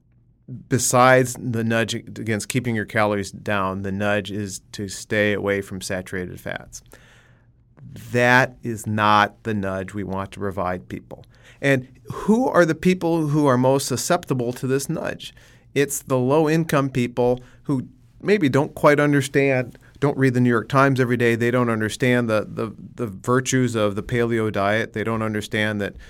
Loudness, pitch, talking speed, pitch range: -21 LUFS, 120 Hz, 165 wpm, 105-135 Hz